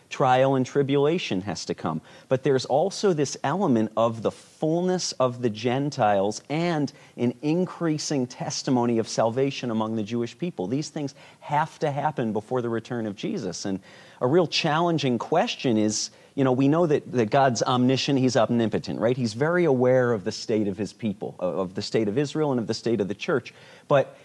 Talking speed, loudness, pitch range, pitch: 190 wpm, -25 LUFS, 115-150 Hz, 130 Hz